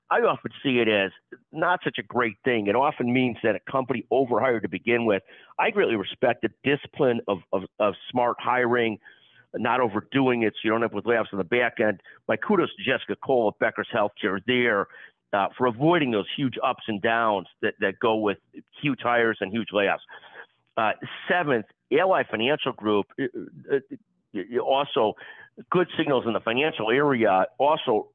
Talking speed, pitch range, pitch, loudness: 175 wpm, 110-135 Hz, 120 Hz, -25 LUFS